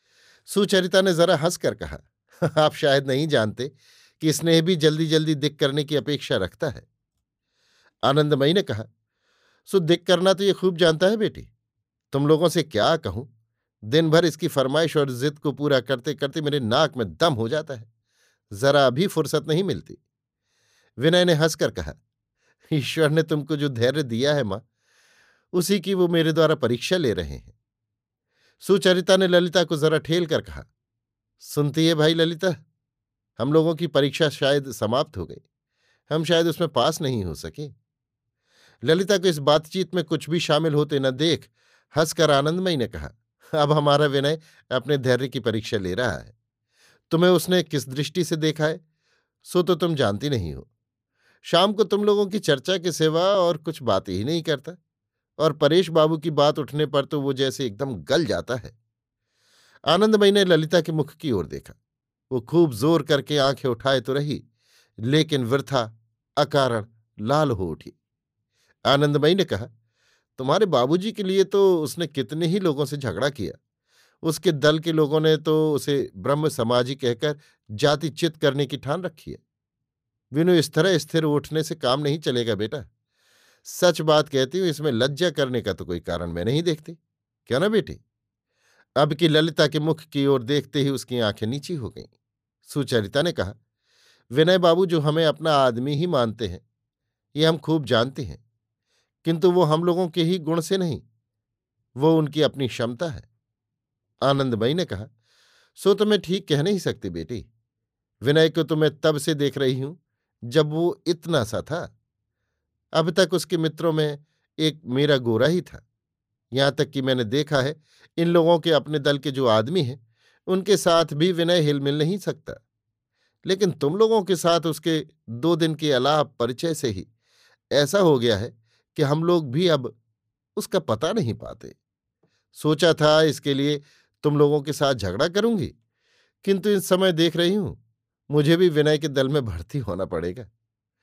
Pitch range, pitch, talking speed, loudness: 120-165 Hz, 150 Hz, 175 wpm, -22 LUFS